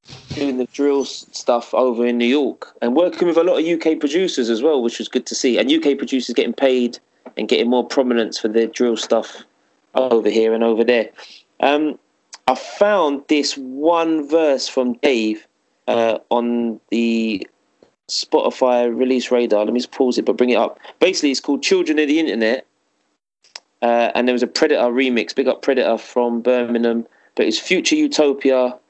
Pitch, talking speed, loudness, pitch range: 125 Hz, 180 wpm, -18 LUFS, 115-145 Hz